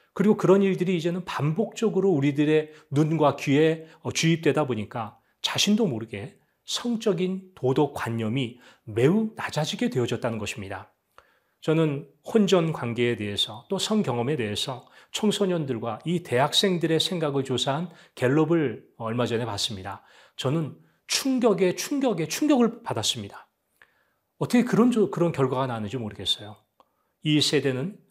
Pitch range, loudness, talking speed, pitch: 120-190 Hz, -25 LUFS, 305 characters per minute, 150 Hz